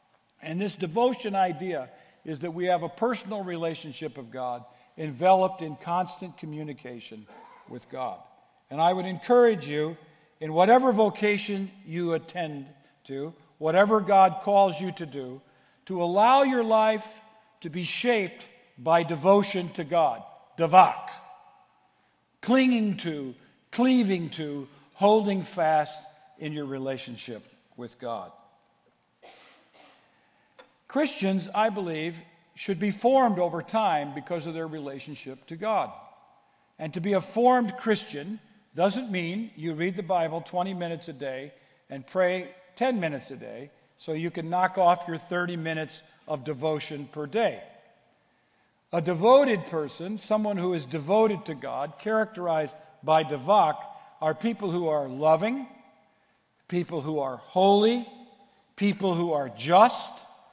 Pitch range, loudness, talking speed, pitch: 155-205 Hz, -26 LUFS, 130 wpm, 175 Hz